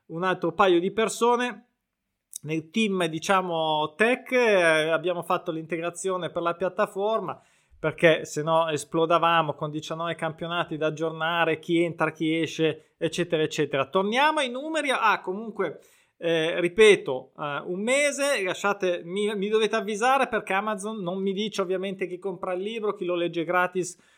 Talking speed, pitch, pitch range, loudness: 150 wpm, 180 Hz, 165-210 Hz, -25 LUFS